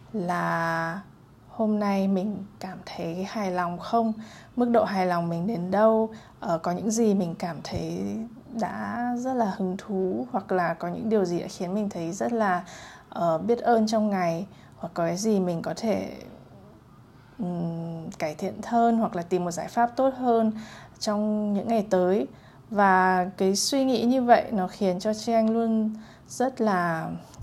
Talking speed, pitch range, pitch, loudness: 175 wpm, 180-225 Hz, 200 Hz, -26 LUFS